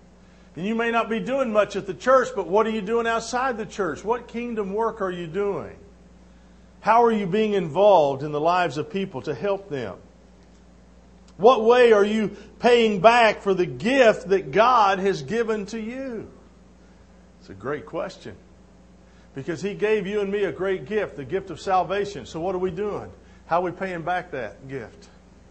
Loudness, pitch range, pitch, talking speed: -22 LUFS, 180-225 Hz, 200 Hz, 190 wpm